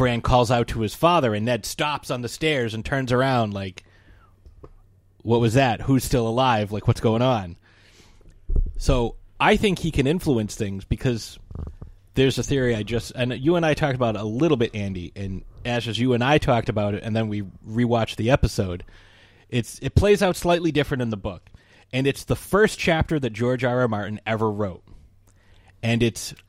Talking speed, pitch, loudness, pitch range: 195 wpm, 115 Hz, -23 LUFS, 100-130 Hz